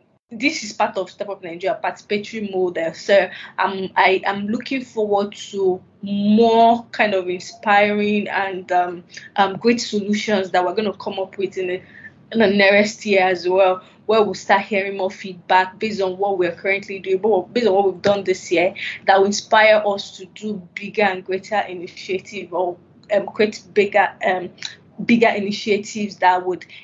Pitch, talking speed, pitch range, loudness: 195 Hz, 175 wpm, 185-210 Hz, -19 LUFS